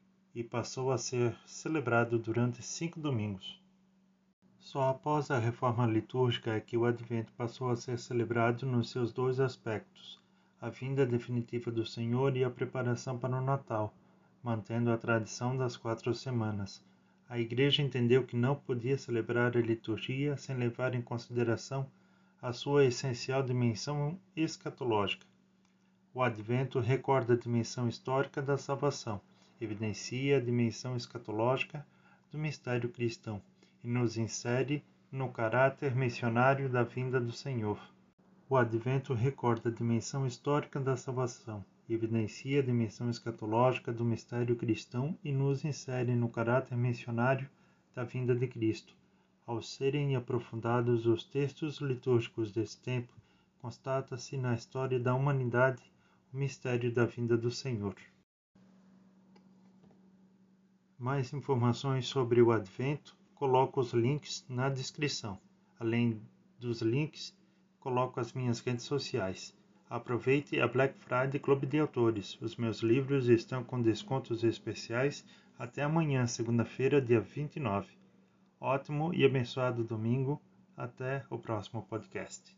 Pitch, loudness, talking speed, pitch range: 125 Hz, -33 LUFS, 125 wpm, 115-140 Hz